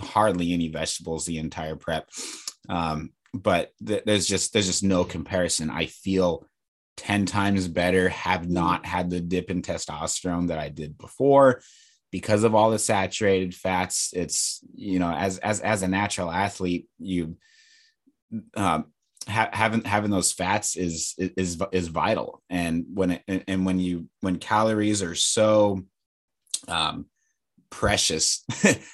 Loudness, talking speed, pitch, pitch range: -25 LUFS, 145 wpm, 95 Hz, 85-100 Hz